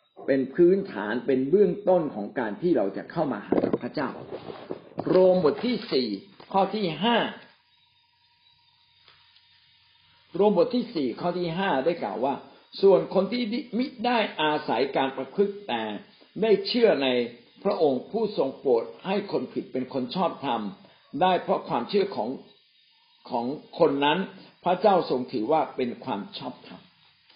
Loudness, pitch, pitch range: -26 LUFS, 195 Hz, 150-220 Hz